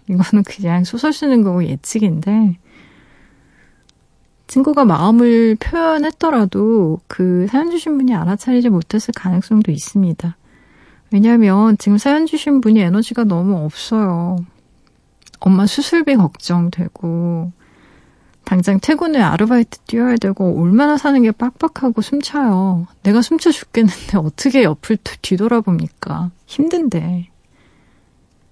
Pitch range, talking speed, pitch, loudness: 180-250 Hz, 275 characters per minute, 210 Hz, -15 LUFS